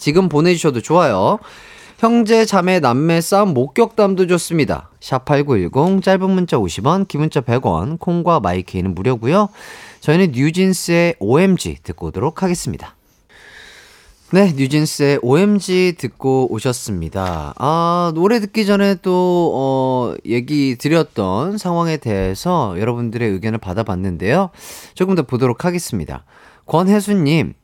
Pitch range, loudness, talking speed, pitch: 125-190 Hz, -16 LUFS, 285 characters per minute, 160 Hz